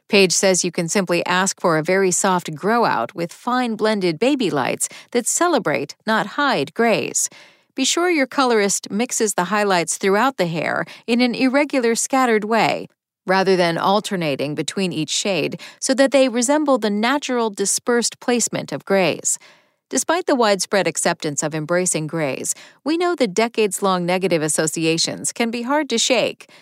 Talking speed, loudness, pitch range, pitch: 160 wpm, -19 LUFS, 180-250 Hz, 205 Hz